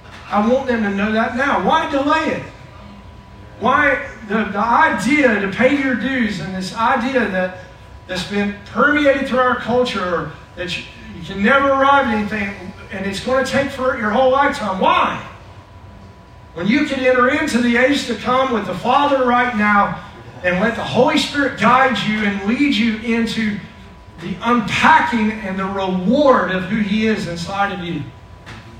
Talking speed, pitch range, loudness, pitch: 175 wpm, 185-260 Hz, -17 LUFS, 220 Hz